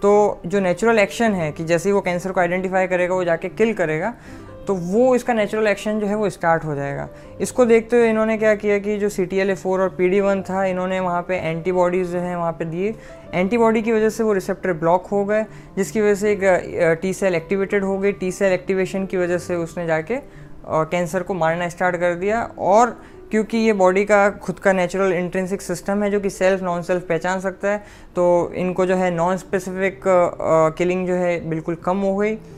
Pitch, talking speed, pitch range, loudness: 185 Hz, 210 wpm, 175-205 Hz, -20 LUFS